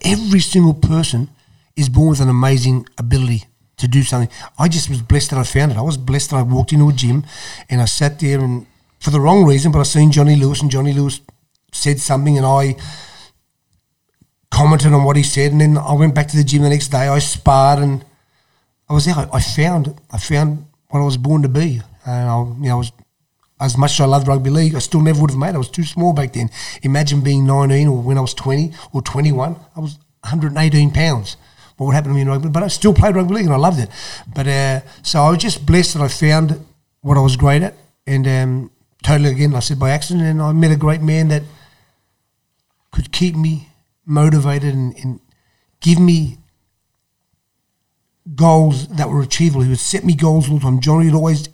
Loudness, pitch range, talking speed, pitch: -15 LUFS, 130-155 Hz, 230 wpm, 145 Hz